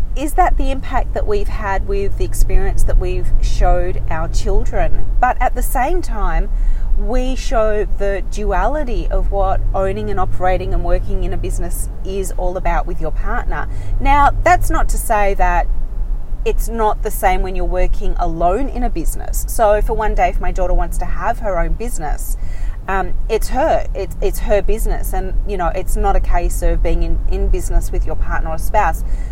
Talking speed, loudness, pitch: 190 wpm, -19 LUFS, 175 Hz